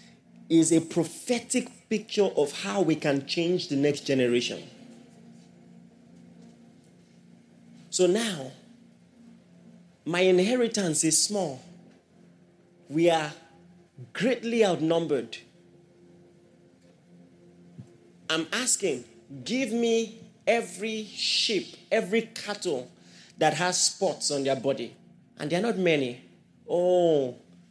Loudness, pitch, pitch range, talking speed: -26 LUFS, 175 Hz, 140-215 Hz, 90 wpm